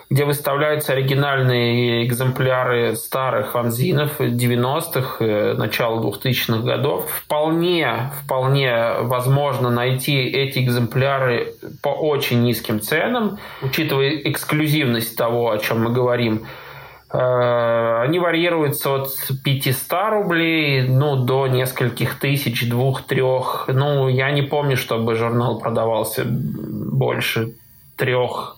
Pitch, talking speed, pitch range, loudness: 130 Hz, 95 wpm, 120-140 Hz, -19 LUFS